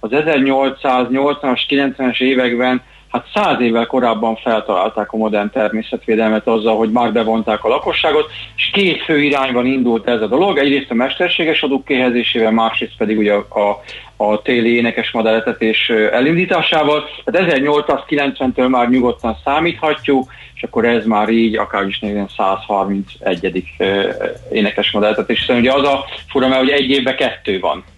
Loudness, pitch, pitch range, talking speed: -15 LUFS, 120 Hz, 110-135 Hz, 140 wpm